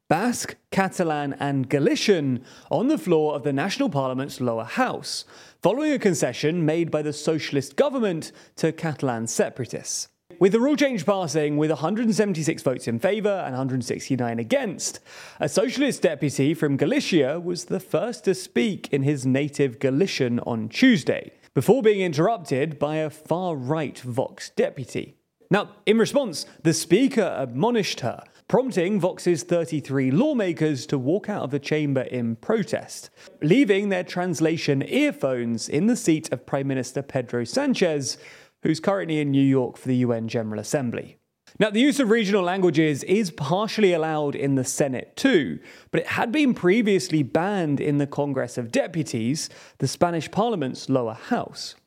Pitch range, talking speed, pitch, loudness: 140-195 Hz, 155 wpm, 155 Hz, -24 LUFS